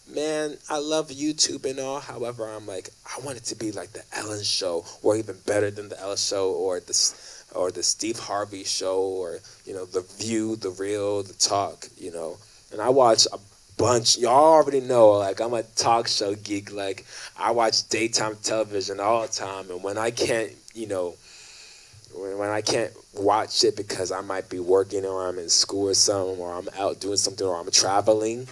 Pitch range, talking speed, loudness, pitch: 100-135 Hz, 200 wpm, -24 LUFS, 105 Hz